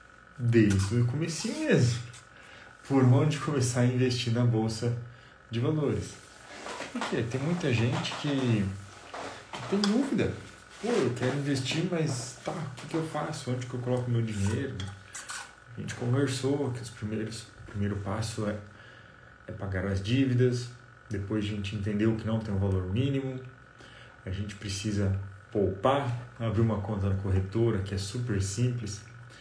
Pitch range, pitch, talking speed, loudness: 105-130 Hz, 120 Hz, 150 wpm, -30 LUFS